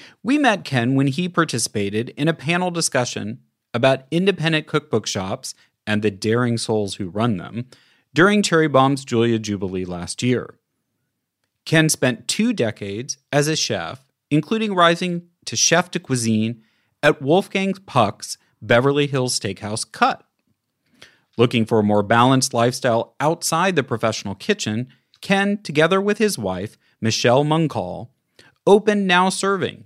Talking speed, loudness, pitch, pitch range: 135 wpm, -20 LUFS, 130 Hz, 115-170 Hz